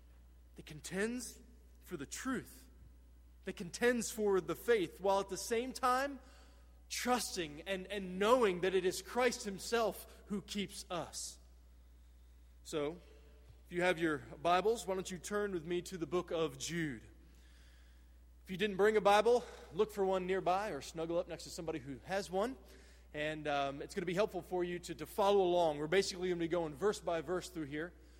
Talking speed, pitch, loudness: 185 wpm, 175 Hz, -37 LUFS